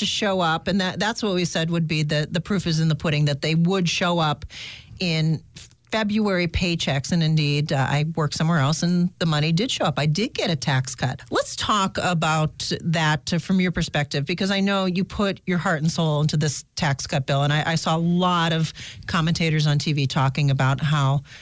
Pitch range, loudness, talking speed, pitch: 150-180 Hz, -22 LUFS, 220 wpm, 160 Hz